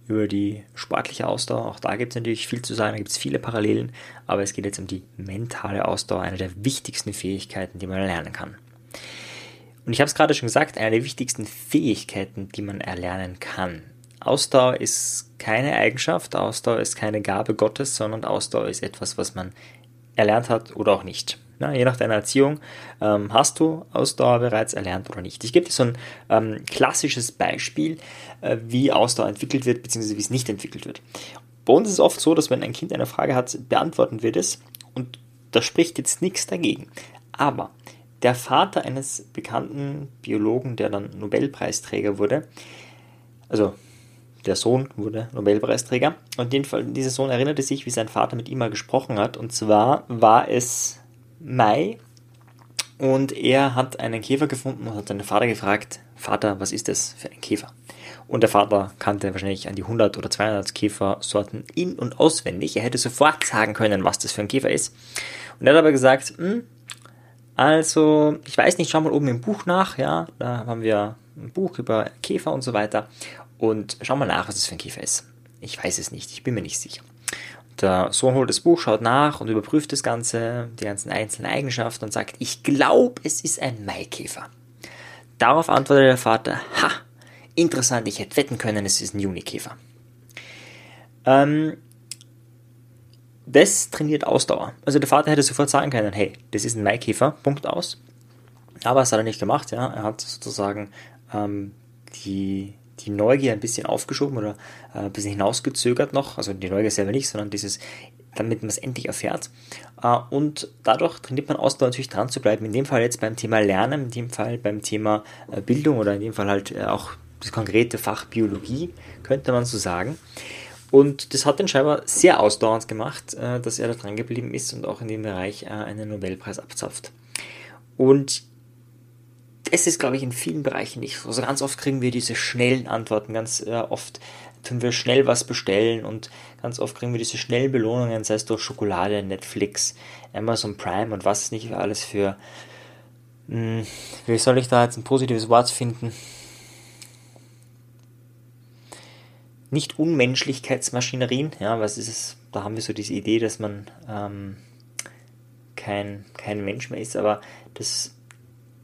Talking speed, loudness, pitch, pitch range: 175 wpm, -22 LUFS, 120 Hz, 105-130 Hz